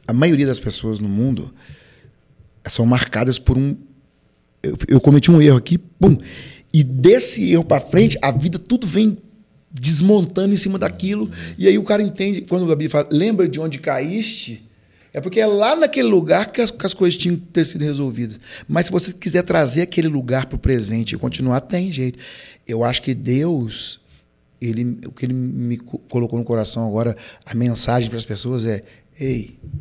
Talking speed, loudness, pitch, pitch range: 185 wpm, -17 LUFS, 135 Hz, 120-180 Hz